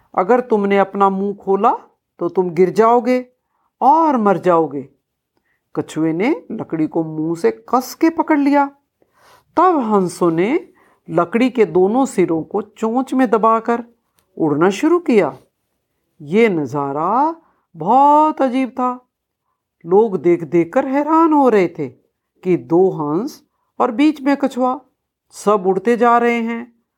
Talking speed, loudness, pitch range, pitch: 135 wpm, -16 LUFS, 180-265 Hz, 225 Hz